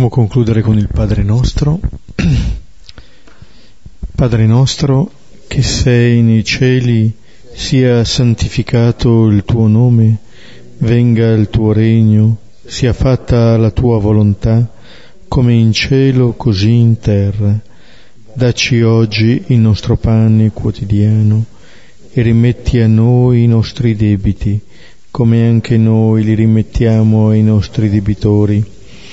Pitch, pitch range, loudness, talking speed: 115 Hz, 110-120 Hz, -11 LUFS, 105 wpm